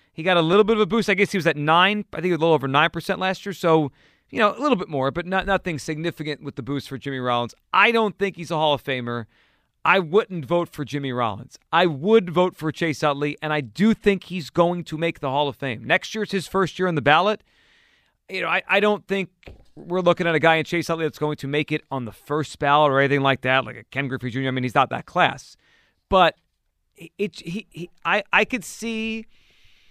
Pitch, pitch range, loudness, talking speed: 170 Hz, 145-195 Hz, -22 LUFS, 260 wpm